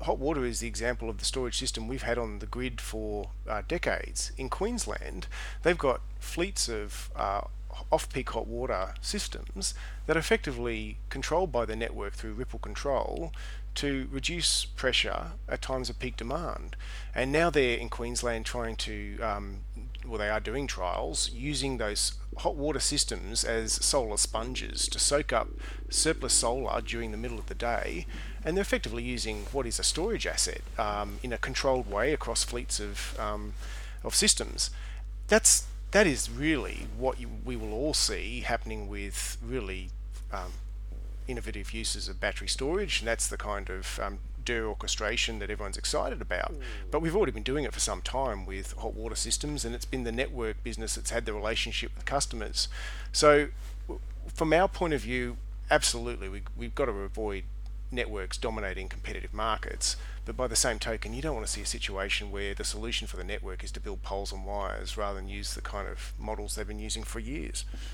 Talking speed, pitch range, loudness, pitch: 185 wpm, 105-125 Hz, -31 LUFS, 115 Hz